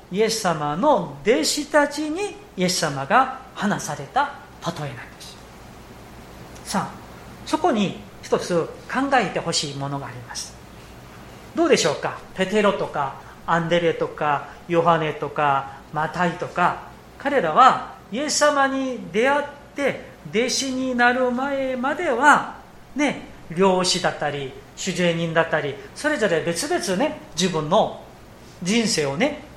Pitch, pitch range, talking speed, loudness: 195 Hz, 165-270 Hz, 245 characters per minute, -22 LUFS